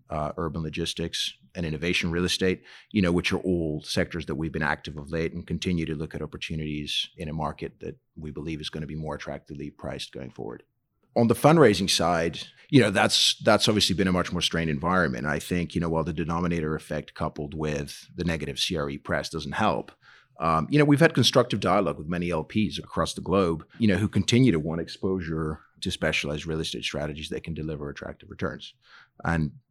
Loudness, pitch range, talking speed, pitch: -26 LUFS, 75-90 Hz, 200 wpm, 80 Hz